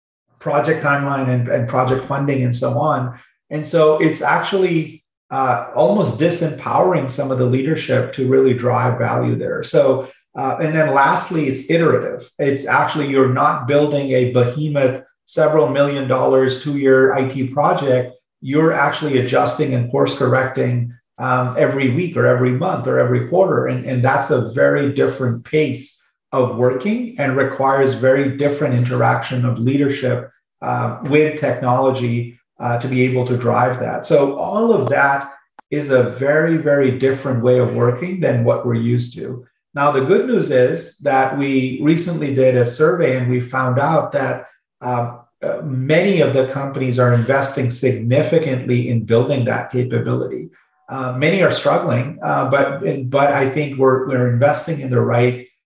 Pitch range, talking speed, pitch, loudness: 125-145 Hz, 160 wpm, 130 Hz, -17 LUFS